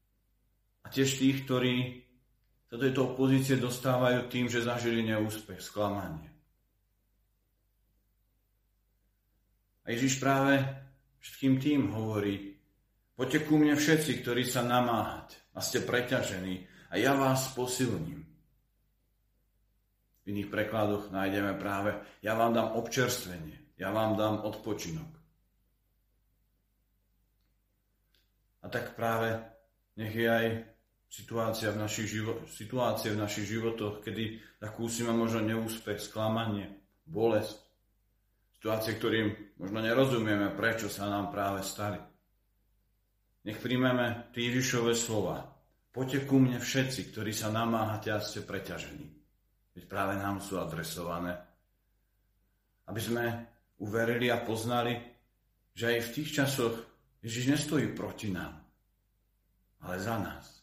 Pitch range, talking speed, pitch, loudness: 100-120 Hz, 110 wpm, 110 Hz, -32 LUFS